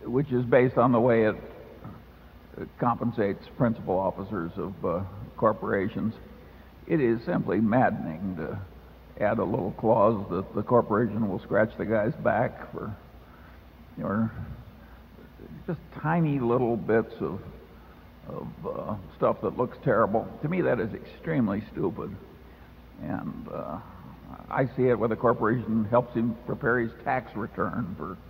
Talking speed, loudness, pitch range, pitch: 140 wpm, -27 LUFS, 100-120 Hz, 115 Hz